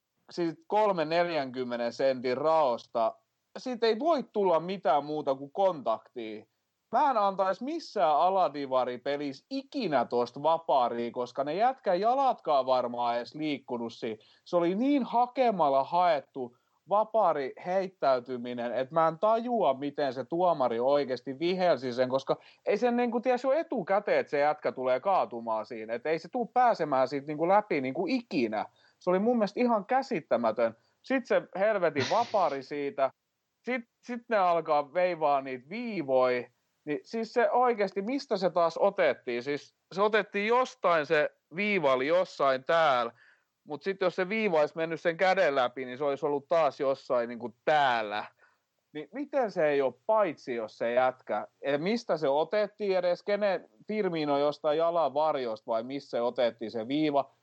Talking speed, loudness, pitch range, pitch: 155 wpm, -29 LUFS, 135-210 Hz, 160 Hz